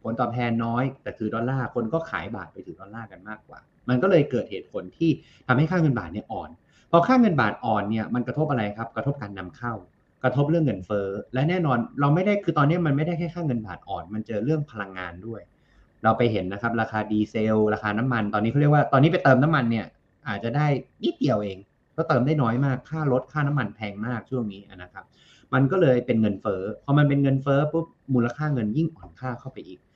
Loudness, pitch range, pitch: -24 LUFS, 110-145 Hz, 125 Hz